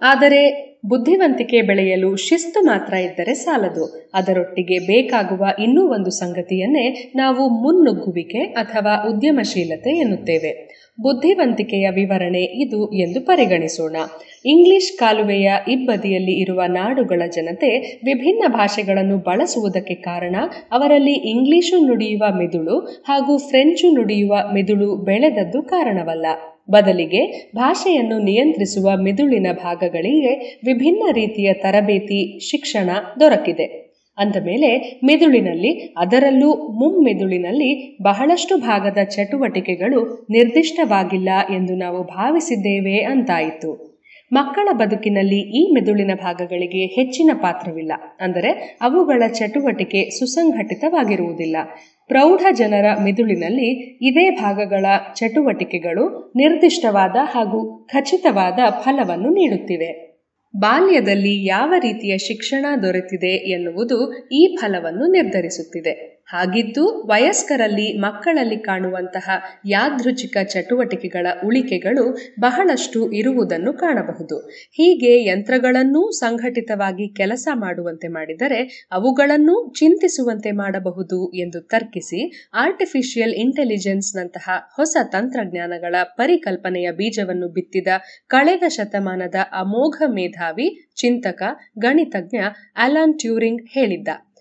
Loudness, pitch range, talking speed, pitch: -17 LUFS, 190-275 Hz, 85 wpm, 220 Hz